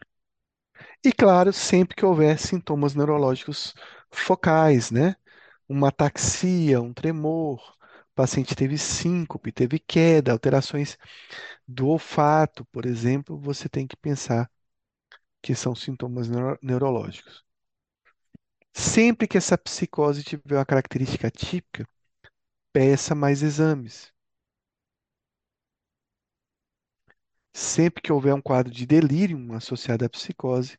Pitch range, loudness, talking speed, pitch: 130-160 Hz, -23 LUFS, 105 wpm, 145 Hz